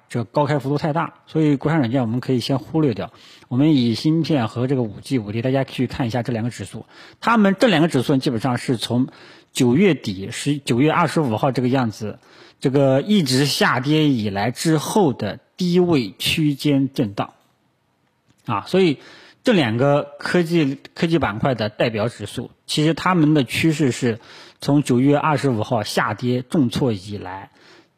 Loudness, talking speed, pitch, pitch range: -20 LUFS, 265 characters per minute, 135 Hz, 120-155 Hz